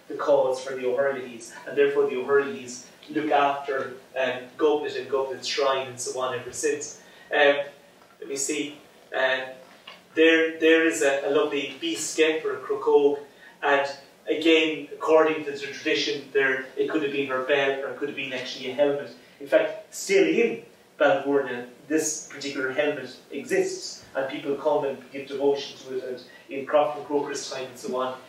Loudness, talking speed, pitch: -25 LUFS, 180 wpm, 145 Hz